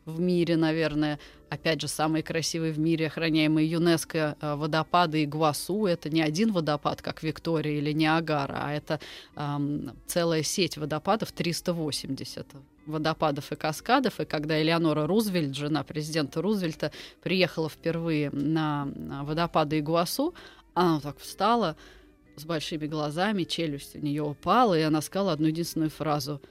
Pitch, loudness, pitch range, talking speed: 155 Hz, -28 LUFS, 150-165 Hz, 140 wpm